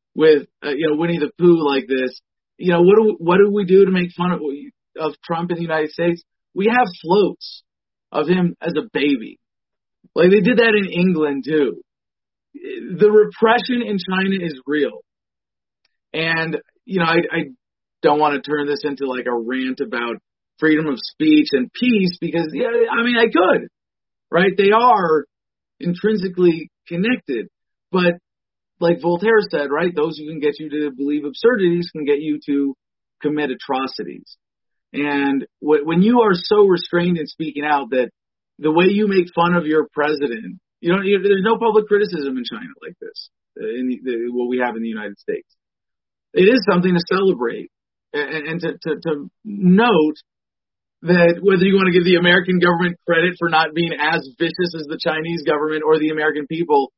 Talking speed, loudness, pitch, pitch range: 180 wpm, -18 LUFS, 170 Hz, 150-195 Hz